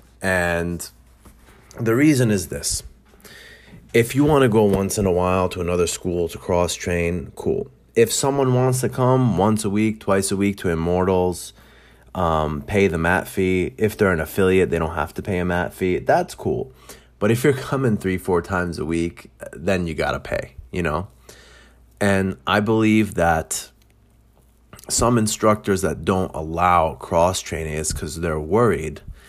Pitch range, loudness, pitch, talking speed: 85-110 Hz, -21 LUFS, 95 Hz, 170 wpm